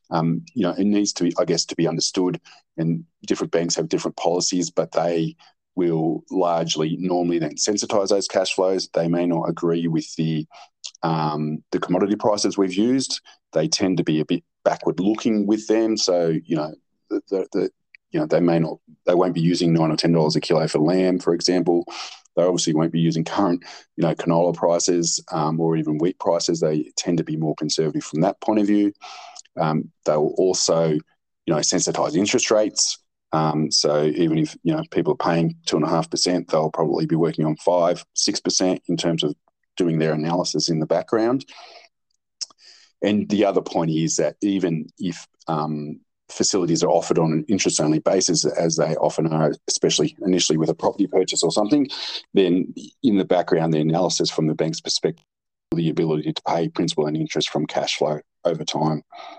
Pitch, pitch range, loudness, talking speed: 85 Hz, 80-90 Hz, -21 LUFS, 190 wpm